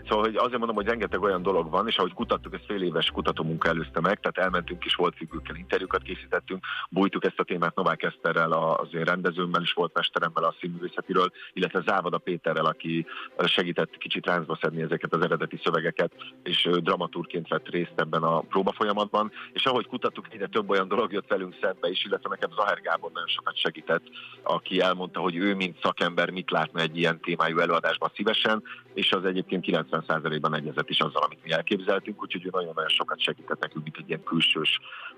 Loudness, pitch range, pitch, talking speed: -27 LUFS, 85-110 Hz, 90 Hz, 190 wpm